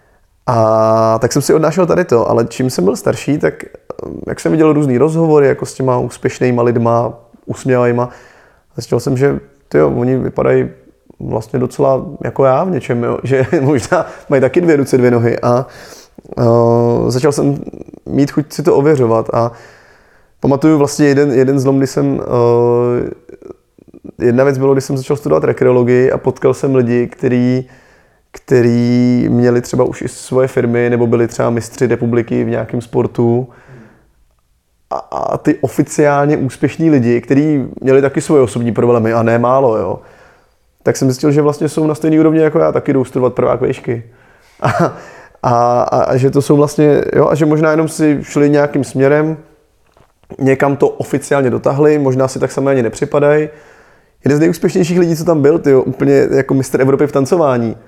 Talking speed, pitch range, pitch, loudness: 170 wpm, 120-145 Hz, 130 Hz, -13 LUFS